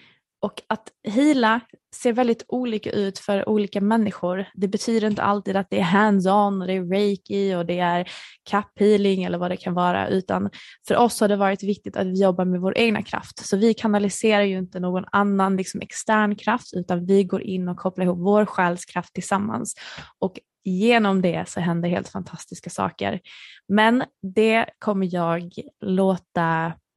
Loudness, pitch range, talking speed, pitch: -22 LUFS, 185-210 Hz, 165 wpm, 195 Hz